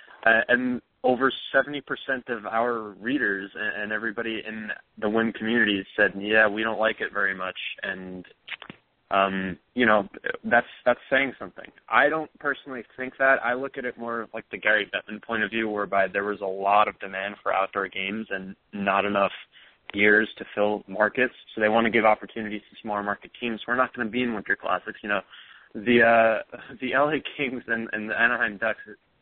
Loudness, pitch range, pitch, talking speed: -25 LUFS, 105-120 Hz, 110 Hz, 190 wpm